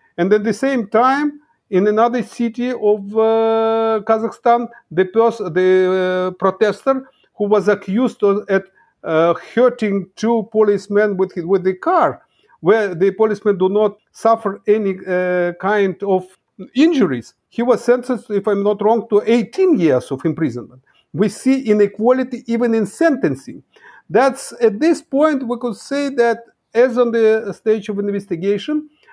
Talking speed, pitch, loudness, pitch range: 150 wpm, 220 Hz, -17 LUFS, 195-245 Hz